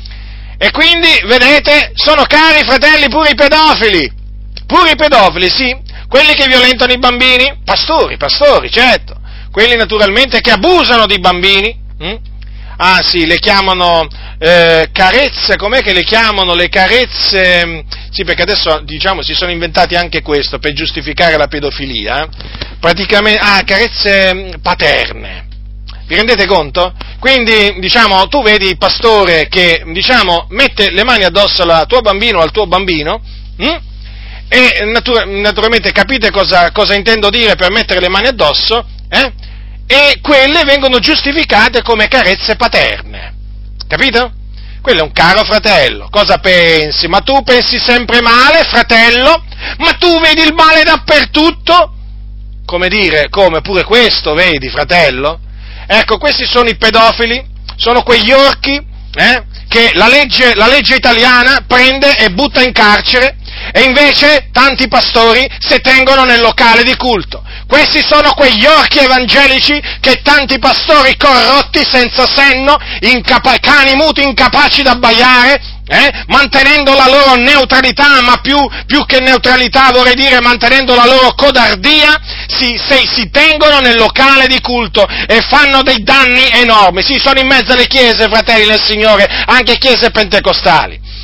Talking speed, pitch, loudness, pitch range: 140 wpm, 235 Hz, -6 LUFS, 185-270 Hz